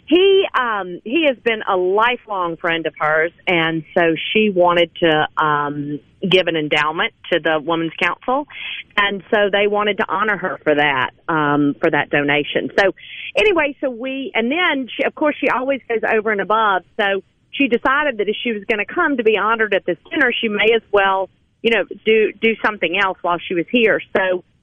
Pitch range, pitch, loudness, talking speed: 170-240 Hz, 200 Hz, -17 LUFS, 200 wpm